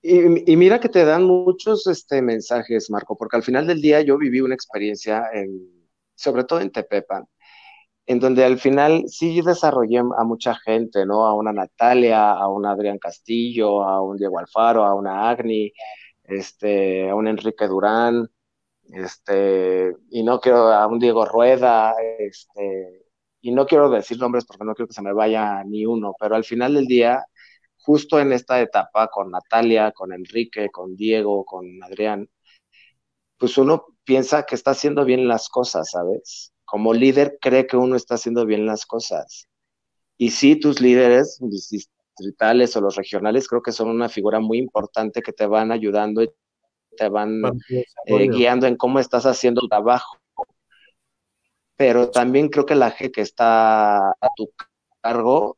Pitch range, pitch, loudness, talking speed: 105-130 Hz, 115 Hz, -19 LUFS, 165 wpm